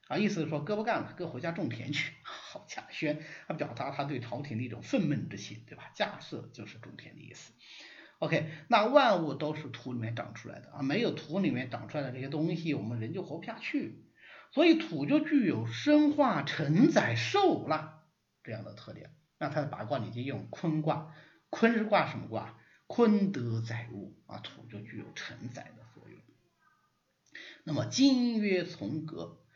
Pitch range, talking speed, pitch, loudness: 130-210 Hz, 270 characters per minute, 155 Hz, -31 LUFS